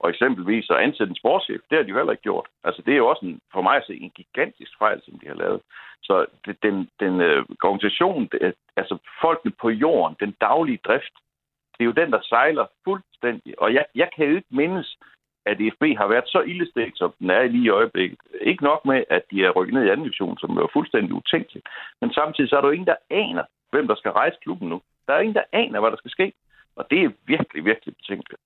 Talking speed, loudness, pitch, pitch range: 240 wpm, -22 LUFS, 120 Hz, 105-140 Hz